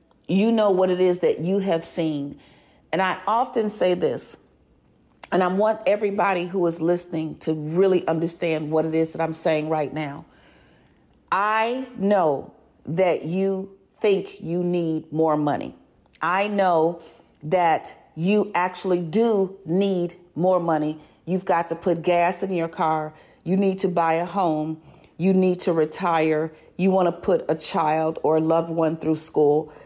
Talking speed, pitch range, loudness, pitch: 160 wpm, 160-190 Hz, -23 LUFS, 175 Hz